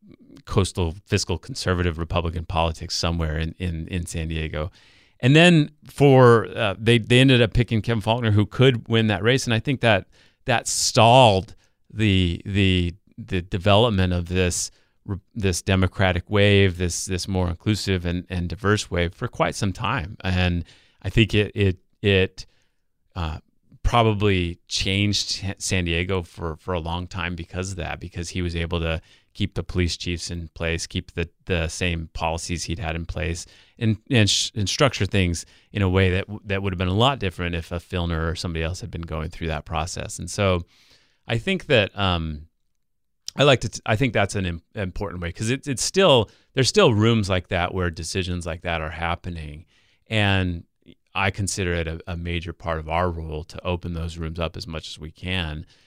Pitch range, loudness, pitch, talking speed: 85-105 Hz, -22 LUFS, 95 Hz, 190 wpm